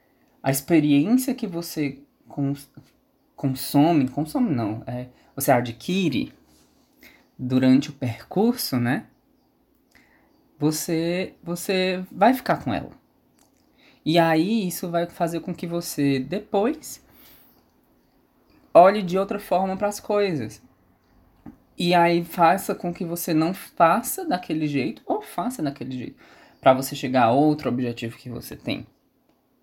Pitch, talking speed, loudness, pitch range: 160 Hz, 120 wpm, -23 LUFS, 135-185 Hz